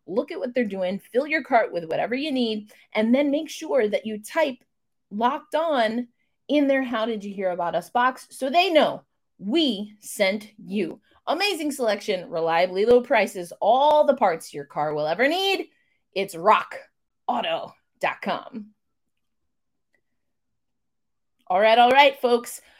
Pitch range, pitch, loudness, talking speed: 205-280 Hz, 240 Hz, -23 LUFS, 145 wpm